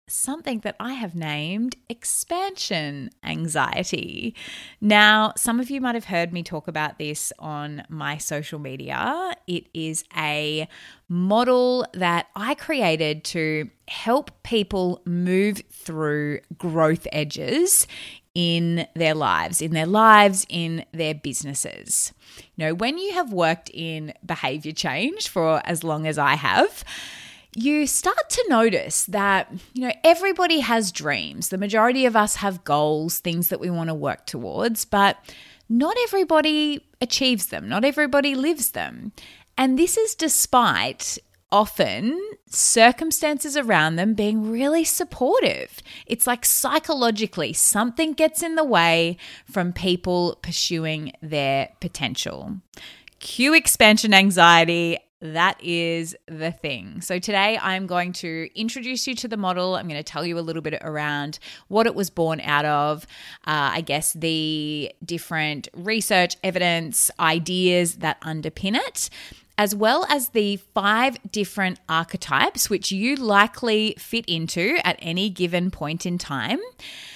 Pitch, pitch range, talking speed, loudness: 185 Hz, 160-235 Hz, 140 wpm, -21 LUFS